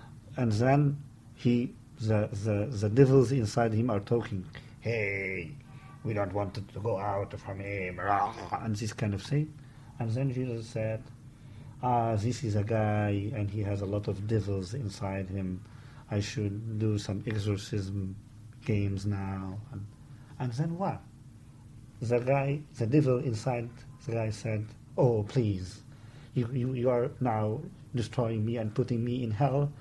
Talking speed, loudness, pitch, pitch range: 155 wpm, -31 LUFS, 115 Hz, 105-130 Hz